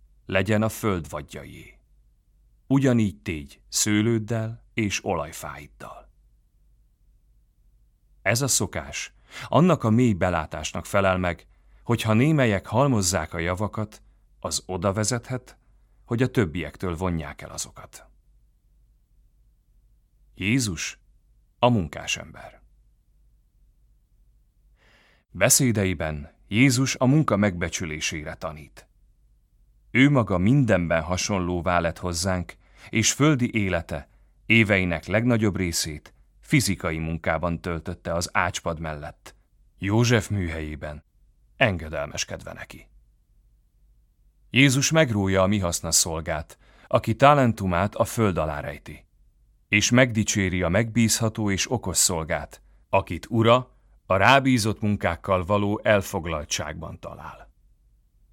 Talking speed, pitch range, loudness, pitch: 95 wpm, 85-115 Hz, -23 LUFS, 100 Hz